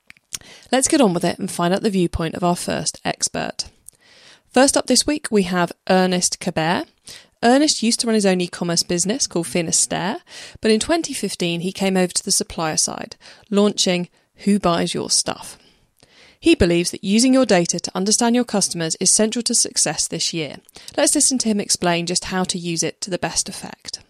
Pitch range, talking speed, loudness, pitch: 175-235 Hz, 195 wpm, -19 LUFS, 195 Hz